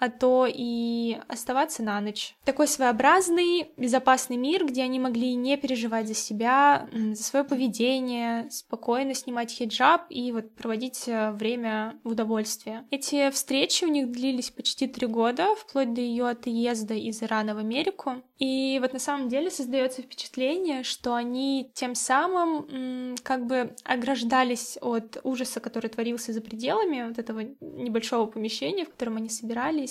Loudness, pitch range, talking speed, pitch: -27 LUFS, 230-270 Hz, 145 wpm, 250 Hz